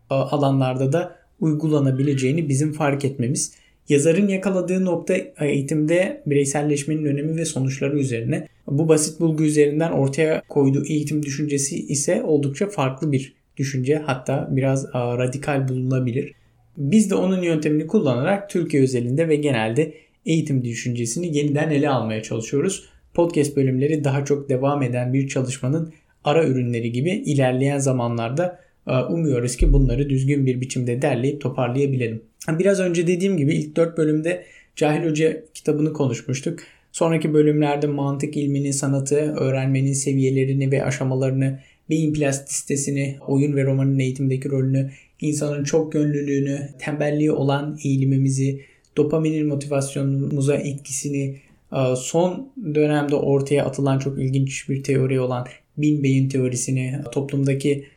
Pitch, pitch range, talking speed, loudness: 140 Hz, 135-155 Hz, 120 wpm, -21 LUFS